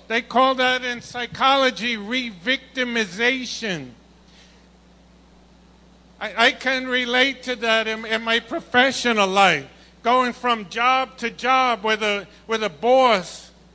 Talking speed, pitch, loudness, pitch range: 120 wpm, 240 Hz, -20 LUFS, 225-255 Hz